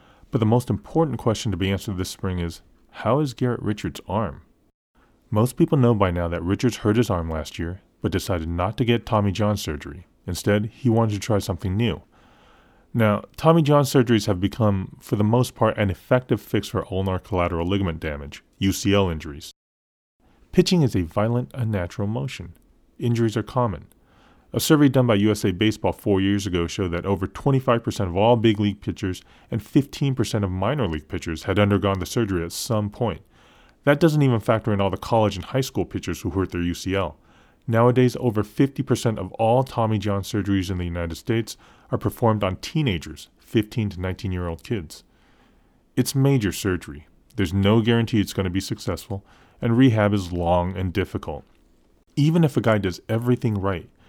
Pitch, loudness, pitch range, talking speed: 105 Hz, -23 LUFS, 95-120 Hz, 185 wpm